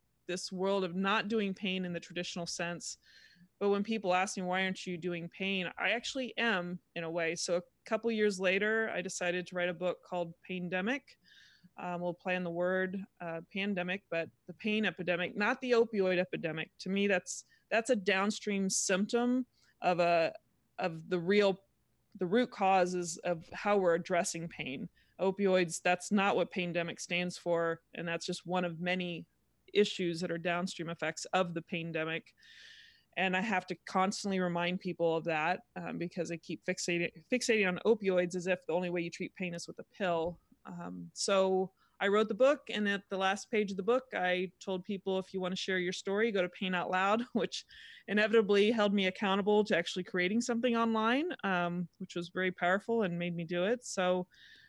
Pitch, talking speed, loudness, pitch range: 185 Hz, 195 wpm, -33 LUFS, 175-205 Hz